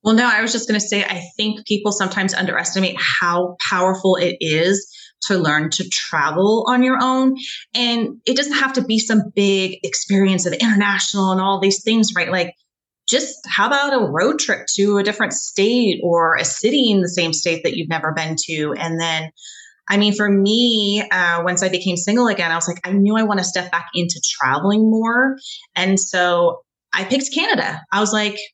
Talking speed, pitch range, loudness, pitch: 200 wpm, 180-225 Hz, -17 LUFS, 200 Hz